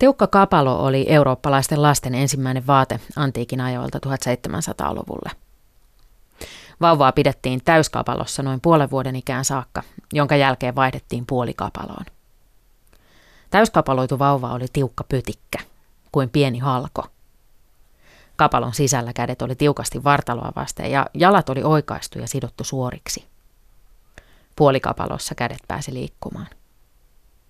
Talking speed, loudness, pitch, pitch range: 105 wpm, -20 LUFS, 135 Hz, 125-145 Hz